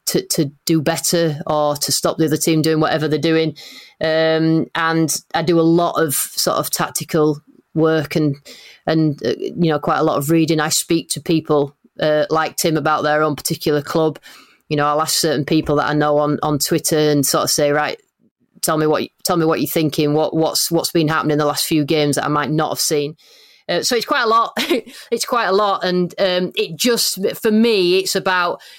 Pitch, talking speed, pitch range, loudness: 160 Hz, 220 wpm, 150-170 Hz, -17 LUFS